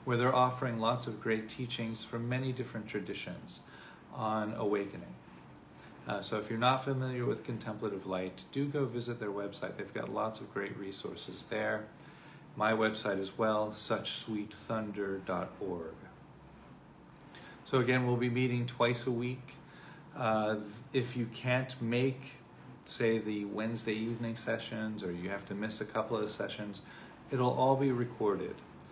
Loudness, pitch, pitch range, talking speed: -35 LUFS, 115 Hz, 105-125 Hz, 145 wpm